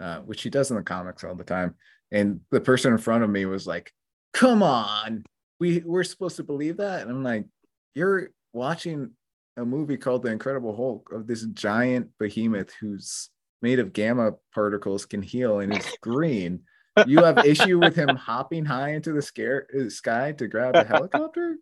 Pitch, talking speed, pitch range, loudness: 125 Hz, 185 wpm, 105-155 Hz, -24 LUFS